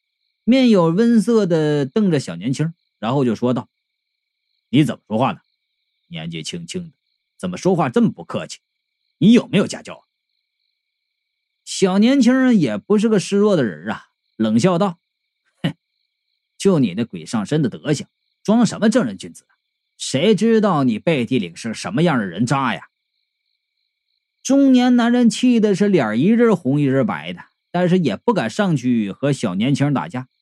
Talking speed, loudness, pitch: 235 characters per minute, -18 LUFS, 225 Hz